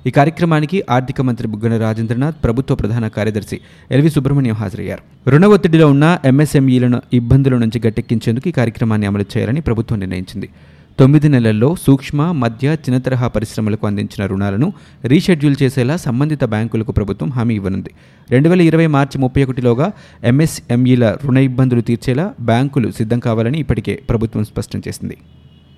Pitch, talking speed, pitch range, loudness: 120 Hz, 135 wpm, 110-140 Hz, -15 LUFS